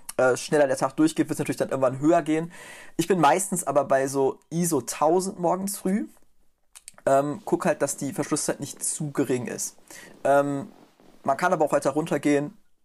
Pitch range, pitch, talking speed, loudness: 140-175 Hz, 150 Hz, 180 wpm, -25 LUFS